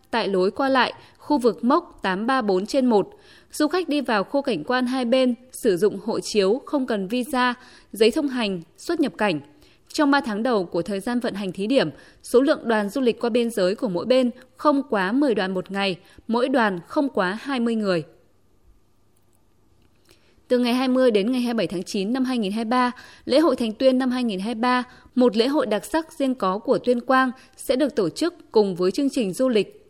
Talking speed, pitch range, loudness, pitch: 200 wpm, 200-260 Hz, -22 LUFS, 240 Hz